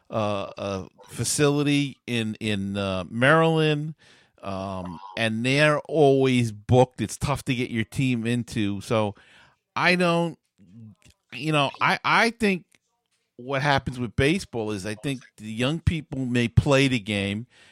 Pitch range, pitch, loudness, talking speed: 110-145 Hz, 125 Hz, -24 LUFS, 140 wpm